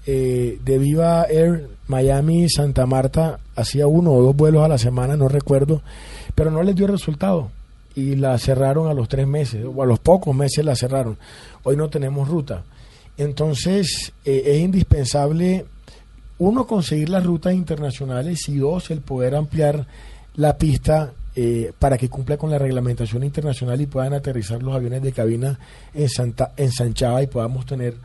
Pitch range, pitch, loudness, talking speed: 125-155 Hz, 140 Hz, -19 LUFS, 165 wpm